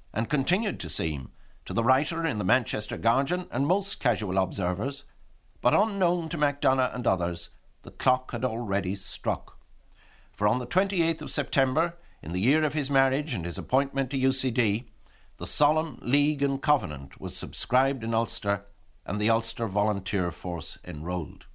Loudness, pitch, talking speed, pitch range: -27 LUFS, 125 Hz, 160 wpm, 95-140 Hz